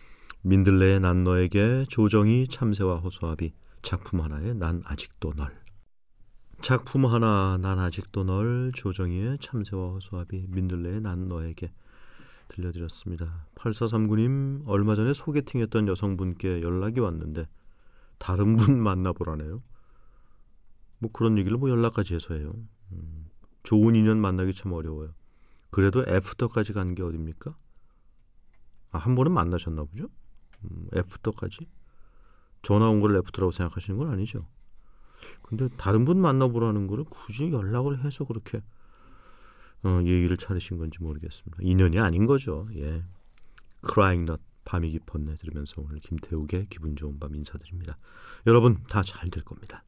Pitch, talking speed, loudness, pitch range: 95 Hz, 305 characters per minute, -26 LUFS, 85-110 Hz